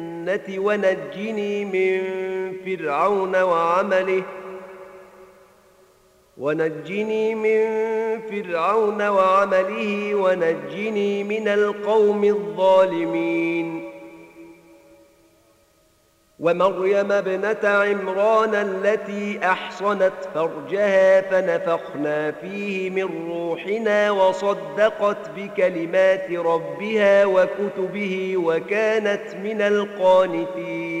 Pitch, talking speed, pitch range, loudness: 190 Hz, 55 wpm, 180-205 Hz, -21 LUFS